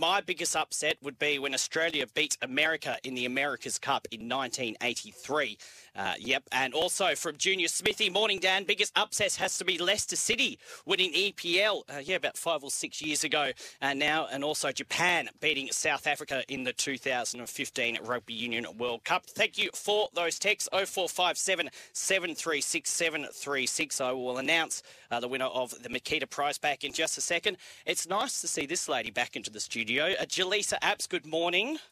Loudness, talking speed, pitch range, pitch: -29 LUFS, 175 wpm, 130-190 Hz, 155 Hz